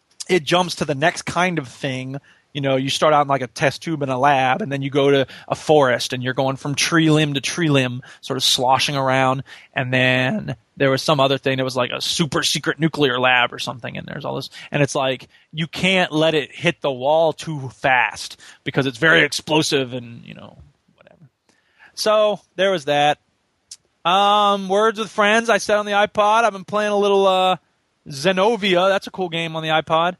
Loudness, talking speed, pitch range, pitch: -18 LUFS, 215 wpm, 135-180 Hz, 155 Hz